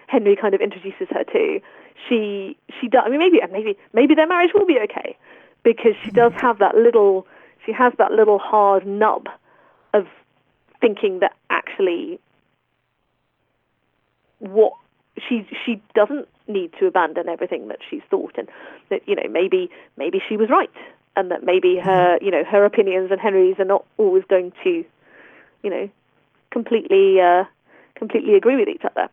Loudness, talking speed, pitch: -18 LUFS, 165 wpm, 240 Hz